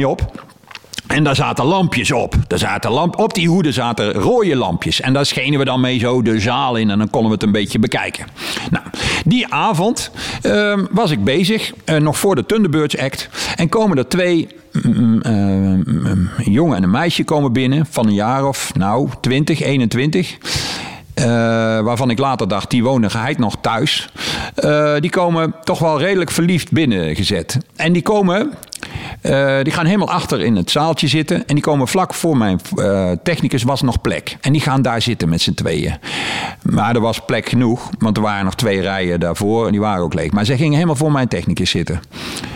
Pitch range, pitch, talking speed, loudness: 110-160 Hz, 135 Hz, 195 wpm, -16 LUFS